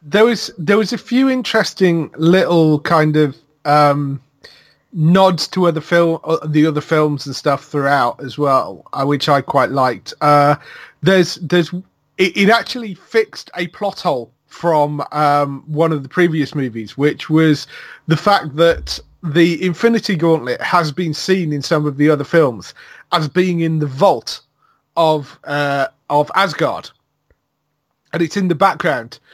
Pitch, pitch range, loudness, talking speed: 160 Hz, 145-180 Hz, -16 LUFS, 155 wpm